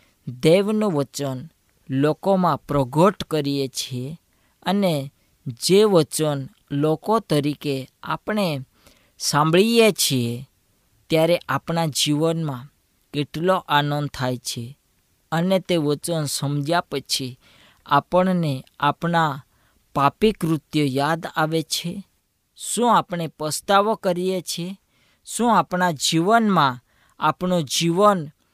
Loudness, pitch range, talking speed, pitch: -21 LUFS, 140-180 Hz, 90 wpm, 155 Hz